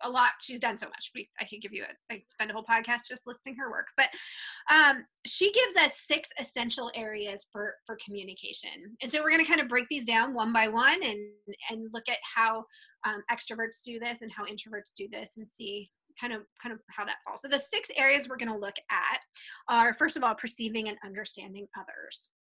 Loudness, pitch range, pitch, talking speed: -29 LUFS, 215-270 Hz, 230 Hz, 225 wpm